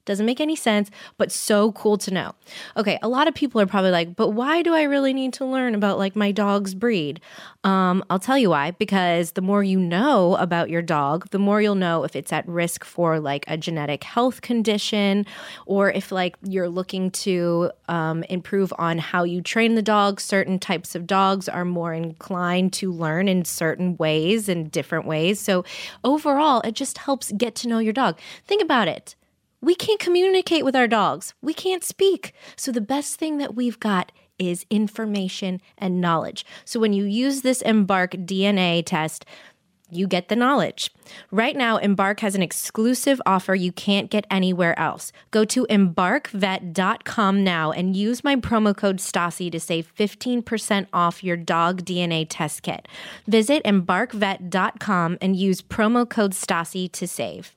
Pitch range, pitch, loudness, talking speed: 180-225 Hz, 195 Hz, -22 LUFS, 180 wpm